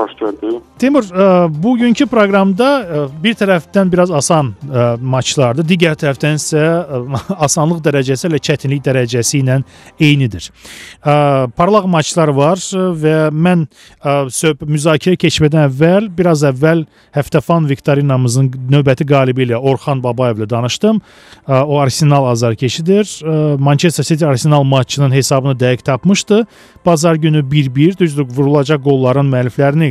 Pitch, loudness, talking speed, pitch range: 150 Hz, -13 LUFS, 120 wpm, 135-170 Hz